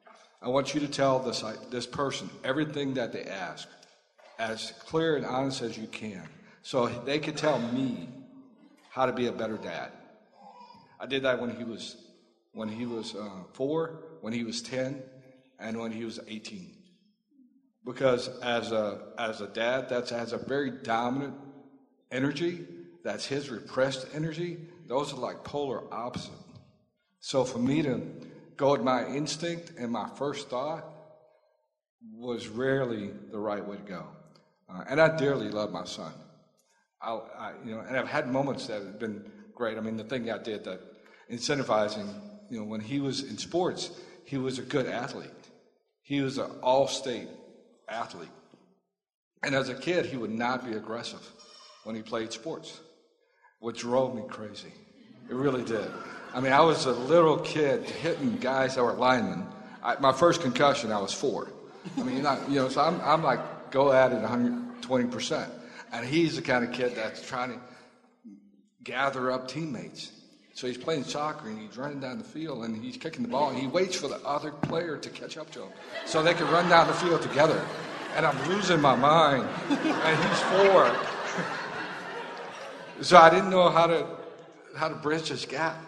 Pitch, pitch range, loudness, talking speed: 135 Hz, 120-160 Hz, -28 LUFS, 175 wpm